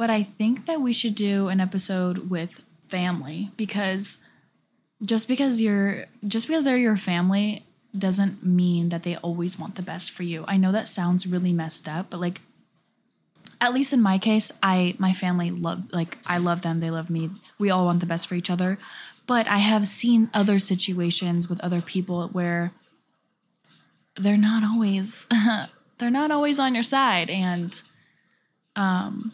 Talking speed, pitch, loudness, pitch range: 170 wpm, 190 Hz, -24 LUFS, 175-220 Hz